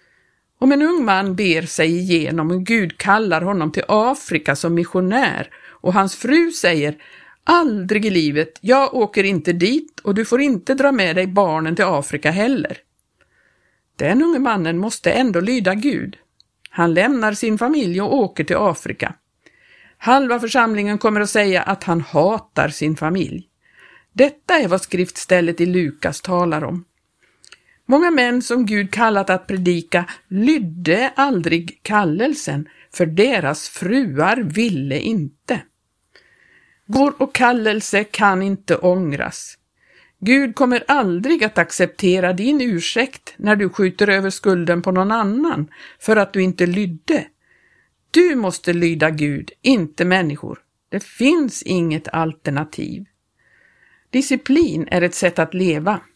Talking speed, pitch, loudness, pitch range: 135 wpm, 195 Hz, -18 LUFS, 175-250 Hz